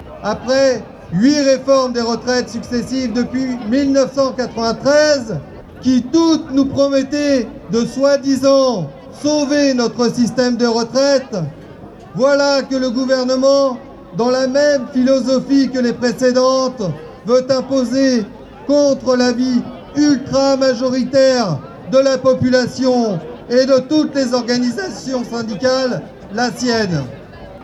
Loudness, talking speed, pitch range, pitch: -15 LUFS, 100 wpm, 240-270 Hz, 255 Hz